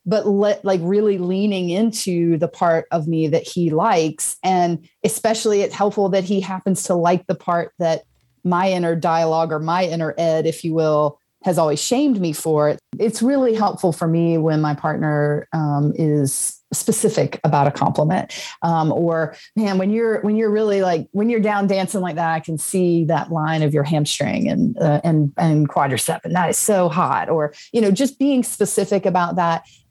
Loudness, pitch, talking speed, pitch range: -19 LUFS, 175 Hz, 190 wpm, 160-200 Hz